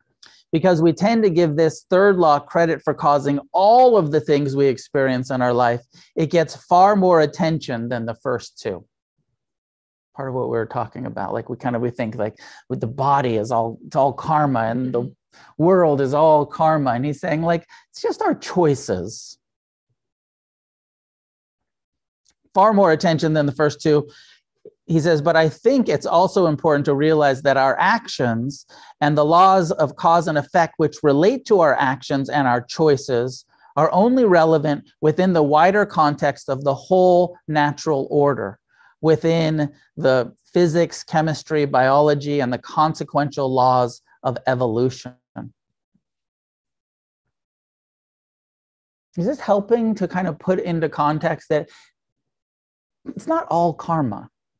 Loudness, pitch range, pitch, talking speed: -19 LUFS, 135-170 Hz, 150 Hz, 150 wpm